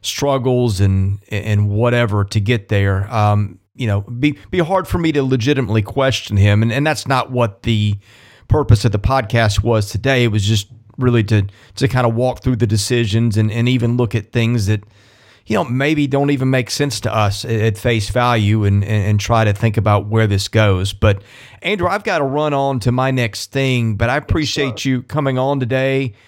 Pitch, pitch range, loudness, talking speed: 115 Hz, 105-130 Hz, -16 LUFS, 205 wpm